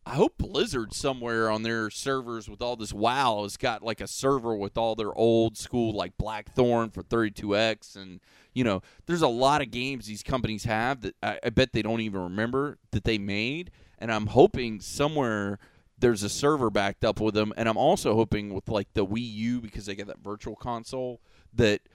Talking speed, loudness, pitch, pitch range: 200 wpm, -27 LUFS, 115 Hz, 105-120 Hz